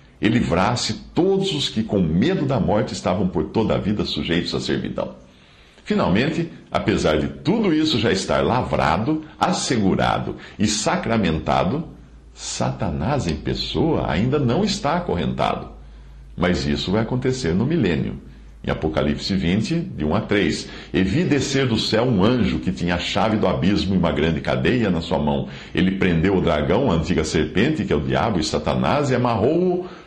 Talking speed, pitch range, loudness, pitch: 165 wpm, 70-115 Hz, -21 LUFS, 85 Hz